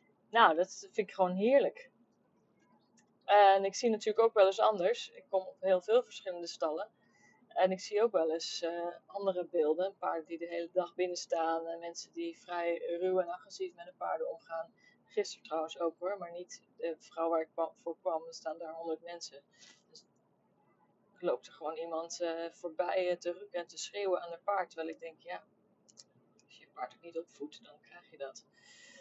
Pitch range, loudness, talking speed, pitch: 165-195 Hz, -34 LUFS, 205 wpm, 175 Hz